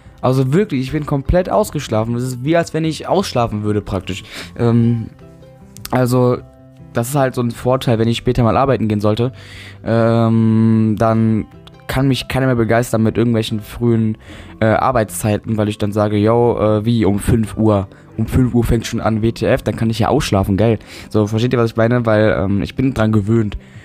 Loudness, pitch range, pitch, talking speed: -16 LUFS, 105-125 Hz, 115 Hz, 195 wpm